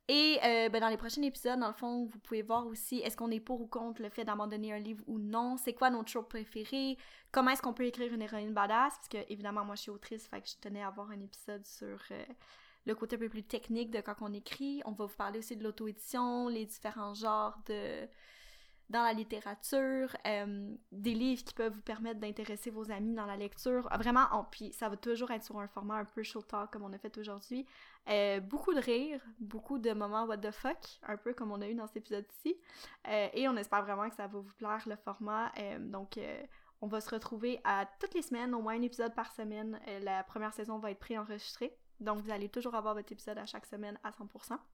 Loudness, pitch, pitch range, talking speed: -38 LUFS, 220 Hz, 210-240 Hz, 240 wpm